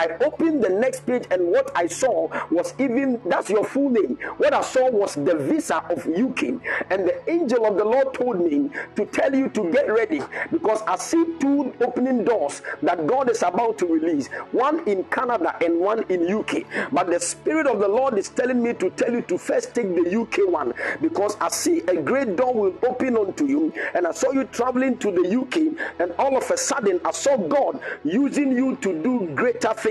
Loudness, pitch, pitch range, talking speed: -22 LUFS, 260 Hz, 225-315 Hz, 215 wpm